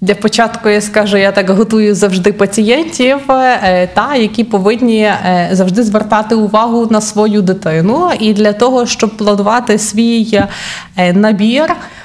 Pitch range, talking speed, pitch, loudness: 205-230 Hz, 125 wpm, 215 Hz, -10 LUFS